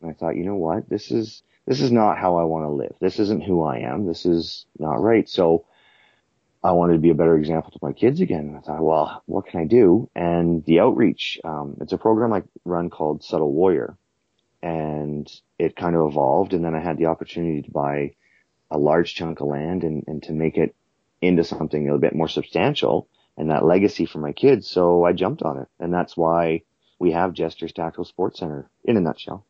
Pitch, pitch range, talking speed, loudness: 80 Hz, 75-85 Hz, 225 wpm, -21 LUFS